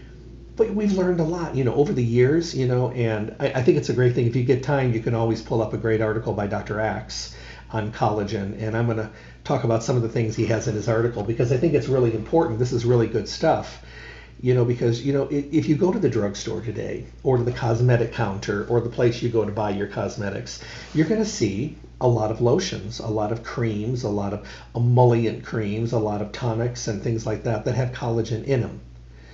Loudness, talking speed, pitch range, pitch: -23 LUFS, 245 wpm, 110-125 Hz, 115 Hz